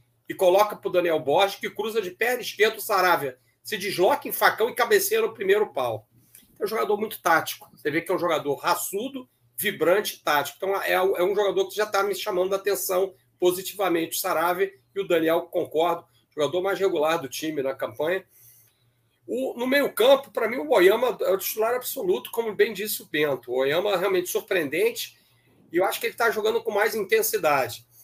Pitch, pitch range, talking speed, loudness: 195 Hz, 160-250 Hz, 195 wpm, -24 LUFS